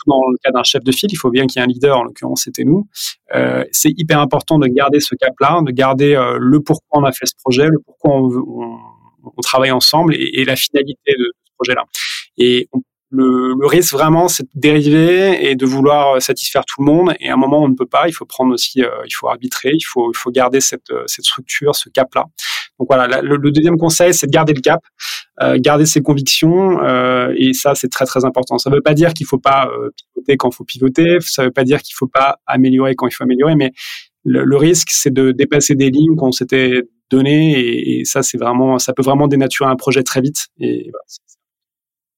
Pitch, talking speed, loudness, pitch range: 135 Hz, 250 wpm, -13 LUFS, 130-150 Hz